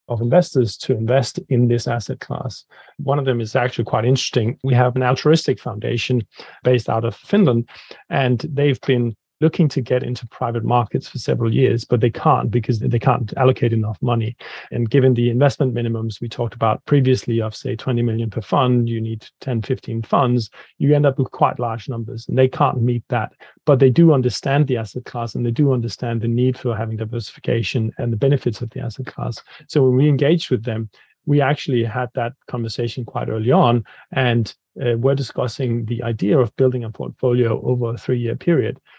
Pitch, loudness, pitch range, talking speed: 125 Hz, -19 LUFS, 115-135 Hz, 200 wpm